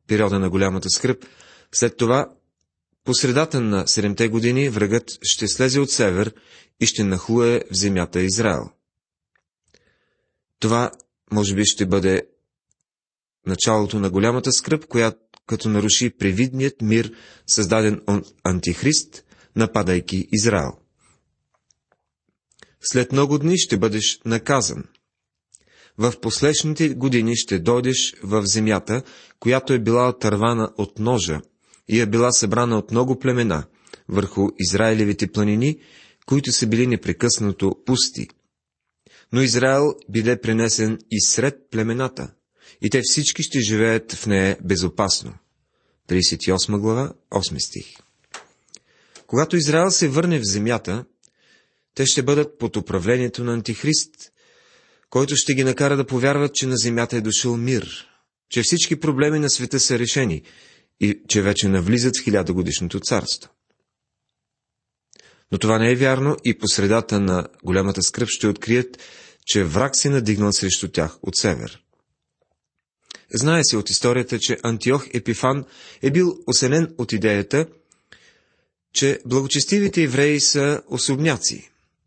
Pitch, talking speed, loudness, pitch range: 115 Hz, 125 wpm, -20 LUFS, 100-130 Hz